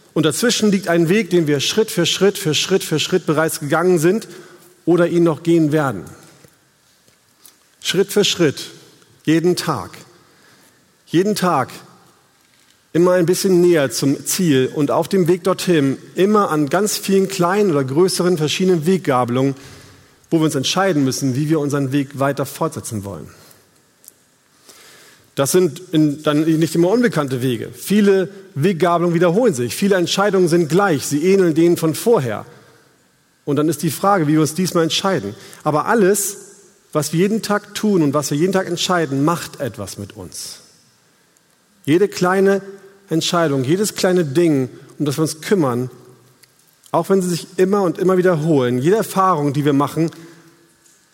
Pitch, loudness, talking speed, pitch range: 170 Hz, -17 LUFS, 155 wpm, 150-190 Hz